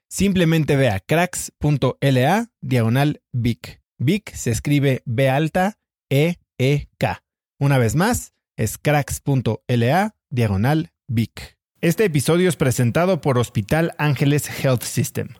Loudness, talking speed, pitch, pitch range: -20 LUFS, 115 wpm, 140 Hz, 120-160 Hz